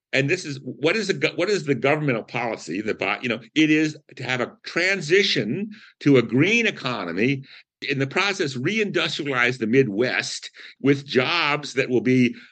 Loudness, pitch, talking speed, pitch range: -22 LUFS, 145 Hz, 170 wpm, 130-175 Hz